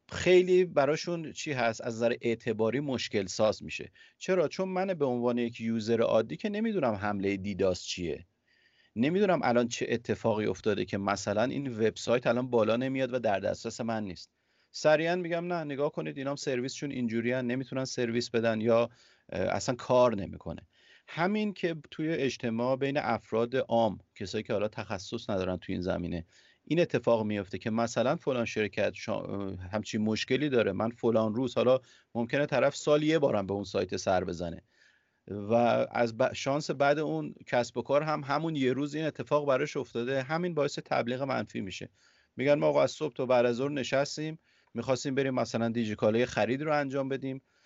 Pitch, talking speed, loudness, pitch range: 125 Hz, 170 wpm, -30 LUFS, 110-145 Hz